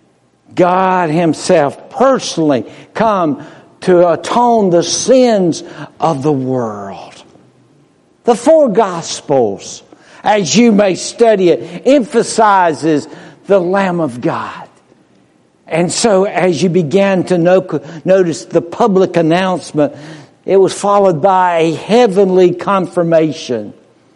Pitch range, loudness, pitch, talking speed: 165-200 Hz, -12 LUFS, 180 Hz, 100 wpm